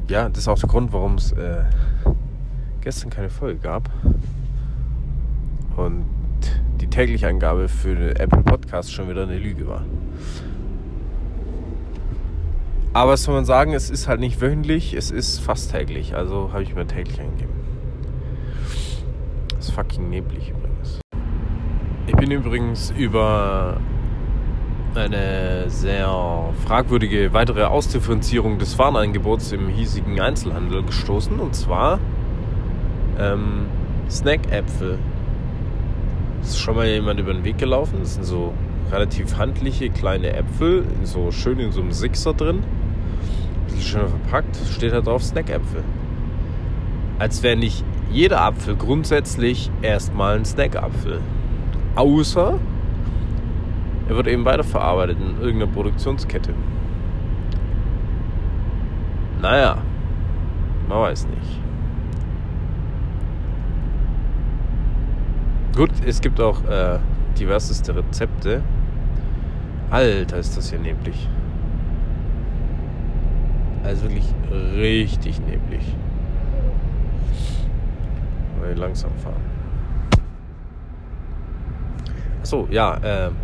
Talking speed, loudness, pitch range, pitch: 100 wpm, -22 LUFS, 80-110 Hz, 95 Hz